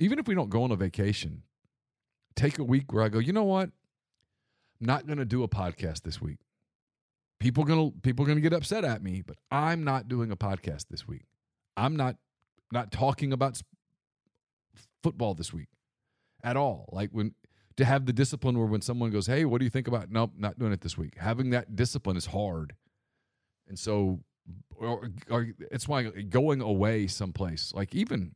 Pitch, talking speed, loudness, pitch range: 120 Hz, 205 wpm, -30 LUFS, 100-135 Hz